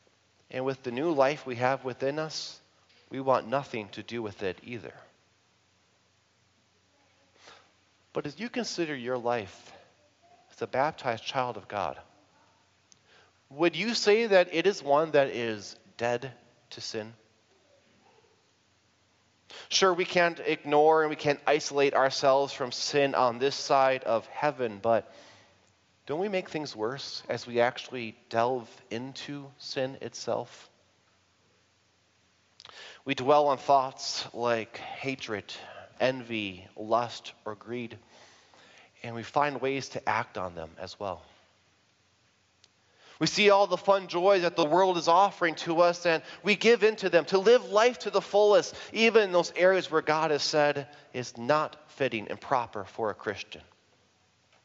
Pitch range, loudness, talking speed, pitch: 110-155 Hz, -28 LUFS, 145 wpm, 130 Hz